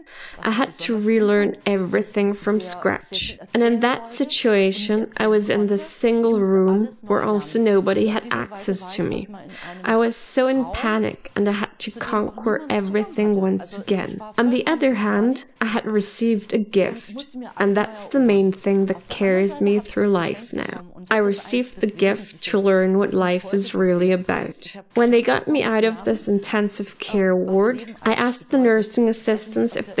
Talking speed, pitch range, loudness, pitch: 170 wpm, 195-230 Hz, -20 LUFS, 210 Hz